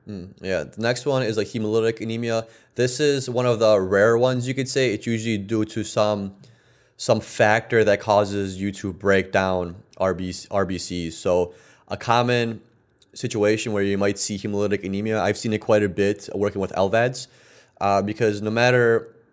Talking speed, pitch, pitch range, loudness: 175 wpm, 105 Hz, 100-115 Hz, -22 LUFS